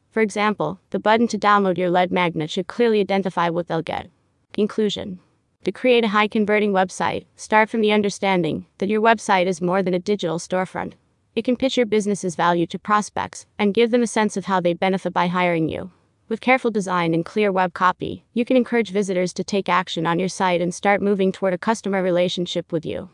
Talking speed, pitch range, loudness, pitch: 205 wpm, 180-215 Hz, -21 LUFS, 195 Hz